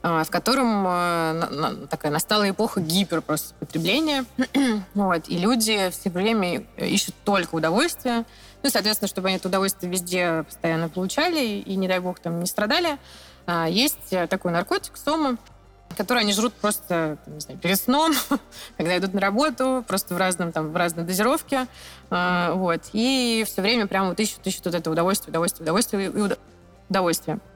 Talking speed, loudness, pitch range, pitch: 170 wpm, -23 LUFS, 170-230 Hz, 190 Hz